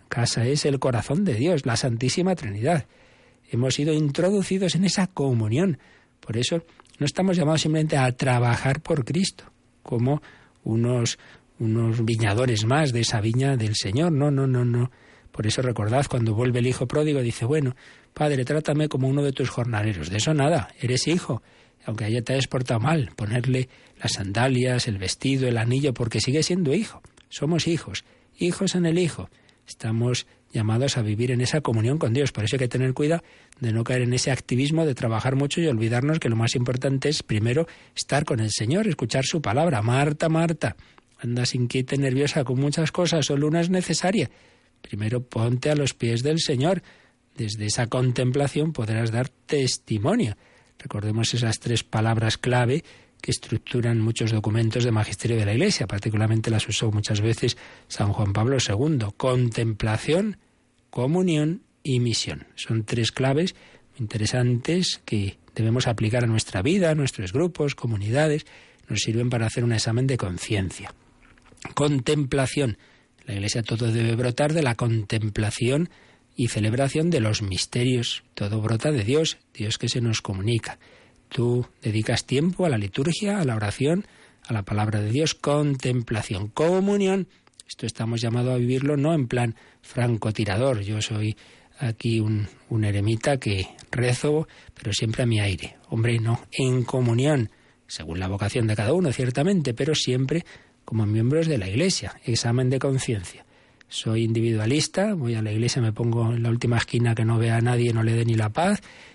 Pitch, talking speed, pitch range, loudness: 125 Hz, 165 wpm, 115-145 Hz, -24 LUFS